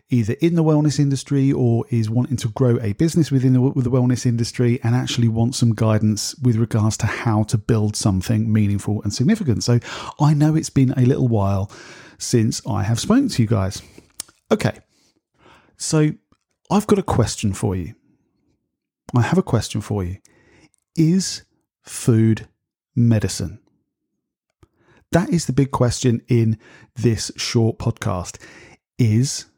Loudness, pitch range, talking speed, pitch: -19 LUFS, 110-135 Hz, 150 wpm, 120 Hz